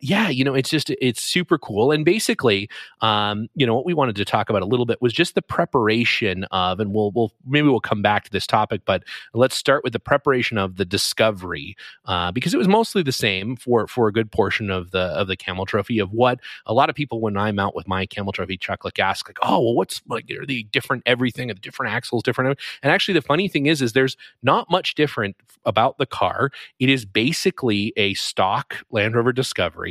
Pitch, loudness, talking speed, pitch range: 120 Hz, -21 LUFS, 235 wpm, 105-140 Hz